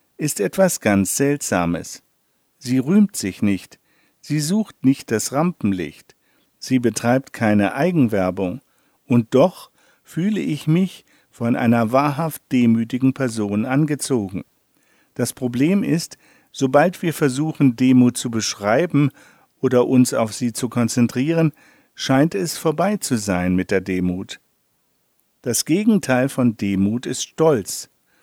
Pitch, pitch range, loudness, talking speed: 130 Hz, 110-150 Hz, -19 LUFS, 120 wpm